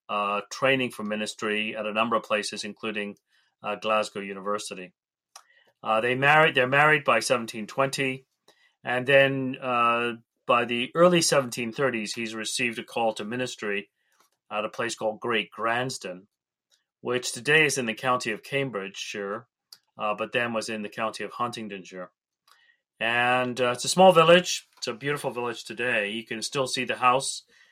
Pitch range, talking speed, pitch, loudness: 105-130 Hz, 160 wpm, 120 Hz, -25 LUFS